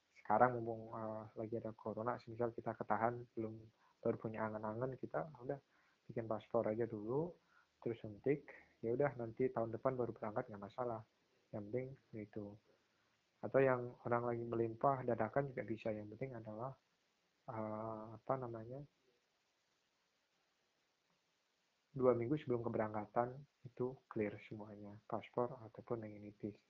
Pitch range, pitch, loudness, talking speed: 110-125 Hz, 115 Hz, -42 LUFS, 130 wpm